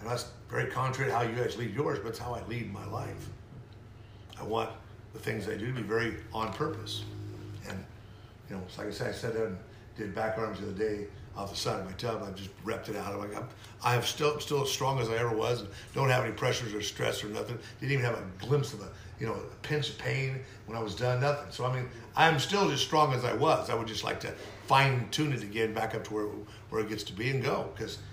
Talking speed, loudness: 265 wpm, -32 LUFS